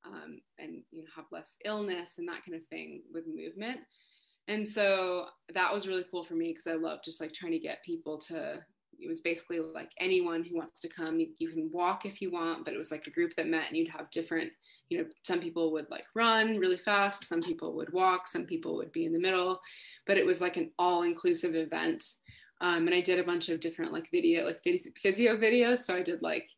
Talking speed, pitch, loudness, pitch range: 235 wpm, 180 Hz, -32 LUFS, 165-240 Hz